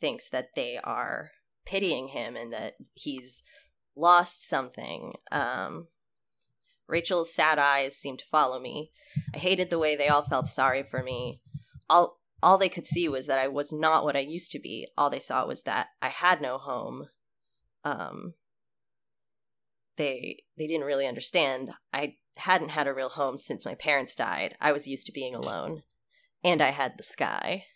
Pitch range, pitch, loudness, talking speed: 130-160 Hz, 145 Hz, -28 LUFS, 175 wpm